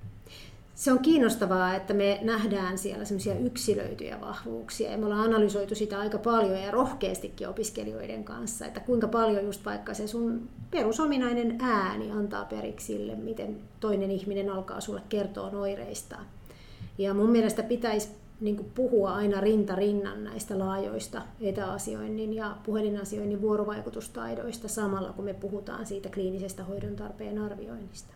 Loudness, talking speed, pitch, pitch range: -30 LUFS, 130 wpm, 205 Hz, 190-215 Hz